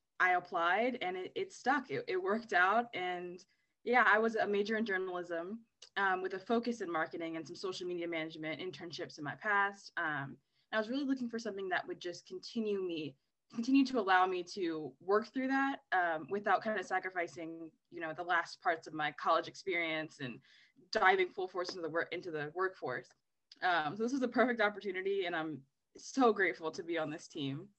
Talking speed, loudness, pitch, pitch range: 200 wpm, -35 LUFS, 185 Hz, 170-235 Hz